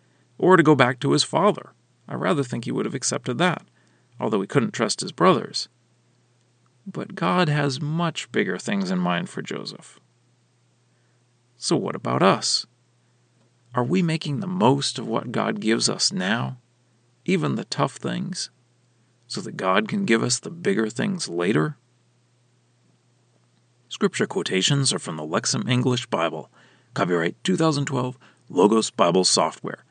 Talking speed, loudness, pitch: 145 wpm, -23 LUFS, 120 Hz